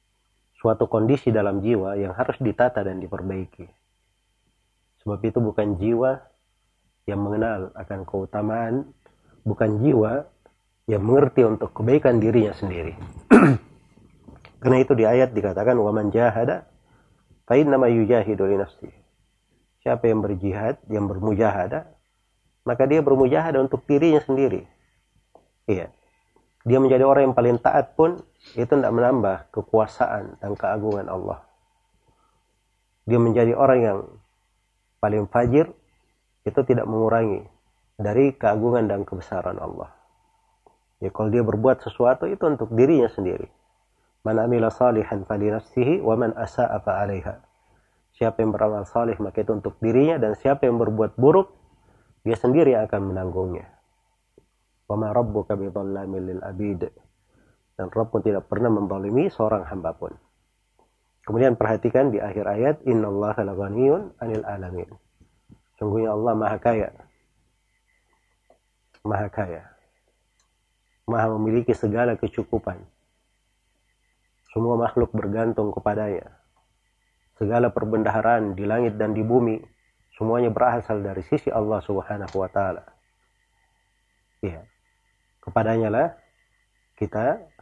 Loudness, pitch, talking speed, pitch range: -22 LUFS, 110 Hz, 110 wpm, 100-120 Hz